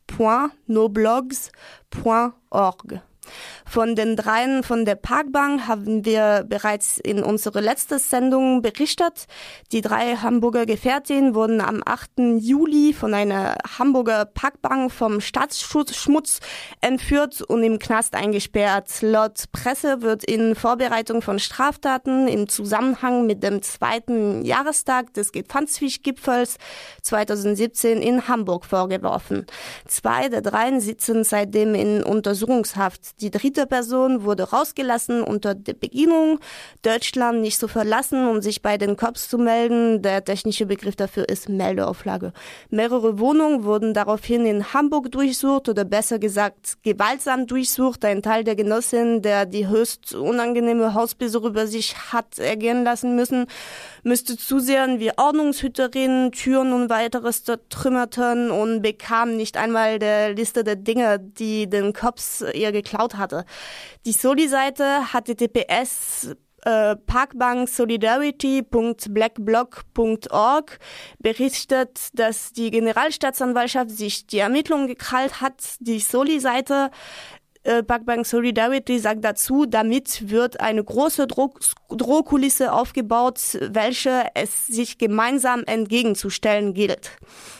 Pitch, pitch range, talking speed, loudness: 235 Hz, 215-260 Hz, 120 wpm, -21 LUFS